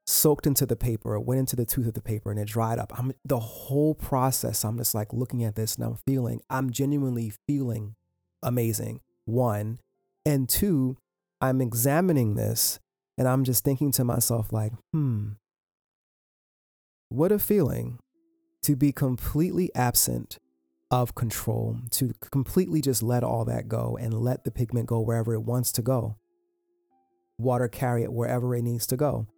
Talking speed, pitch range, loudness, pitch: 165 wpm, 110-135 Hz, -26 LUFS, 120 Hz